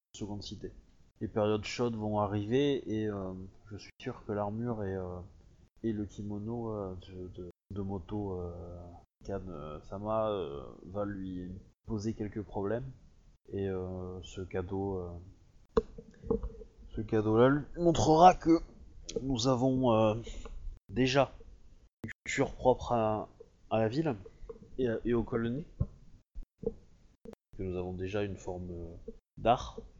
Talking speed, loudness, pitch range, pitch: 130 wpm, -33 LUFS, 90-115 Hz, 105 Hz